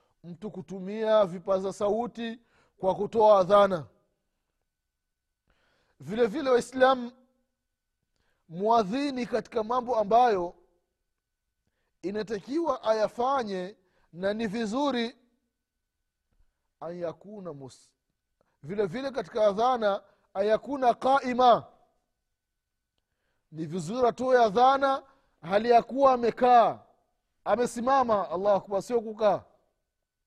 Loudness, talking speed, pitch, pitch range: -26 LUFS, 75 wpm, 220 Hz, 190-245 Hz